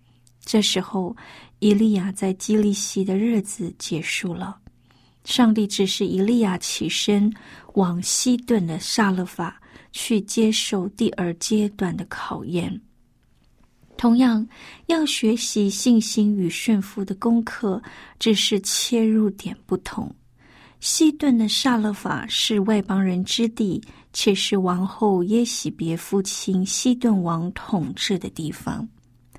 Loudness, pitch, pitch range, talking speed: -22 LUFS, 205 Hz, 185-225 Hz, 185 characters per minute